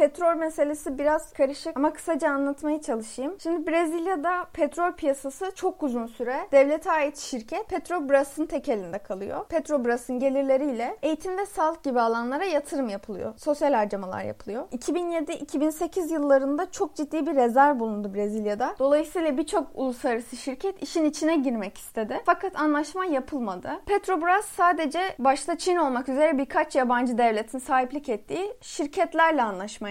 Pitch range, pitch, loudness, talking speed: 260-335 Hz, 295 Hz, -26 LUFS, 130 wpm